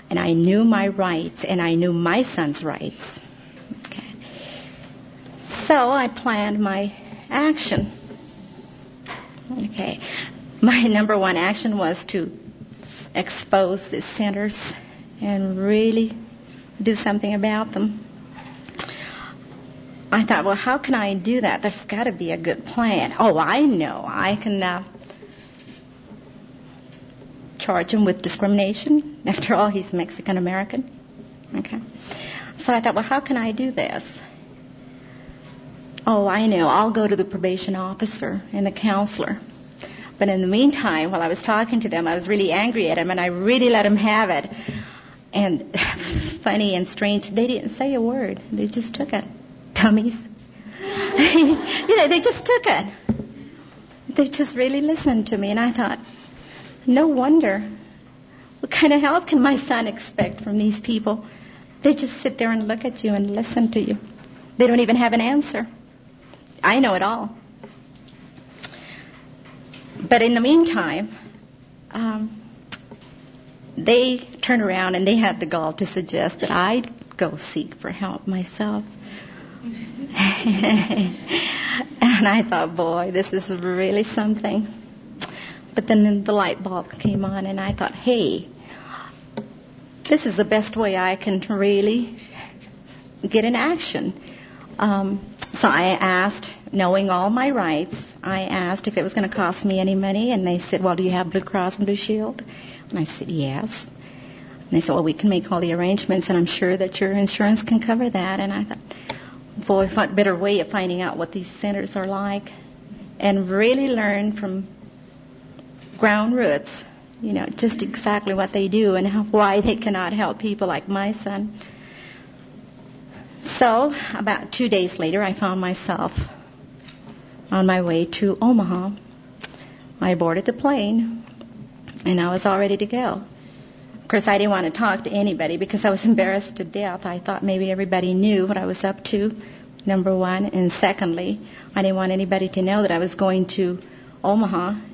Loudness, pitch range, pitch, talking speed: -21 LUFS, 190-230 Hz, 205 Hz, 160 wpm